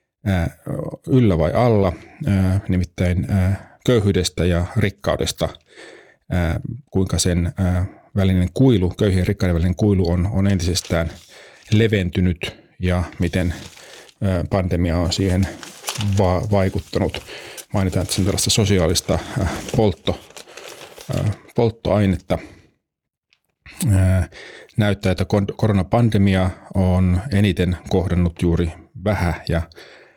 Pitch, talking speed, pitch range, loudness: 95 Hz, 80 wpm, 90-100 Hz, -20 LUFS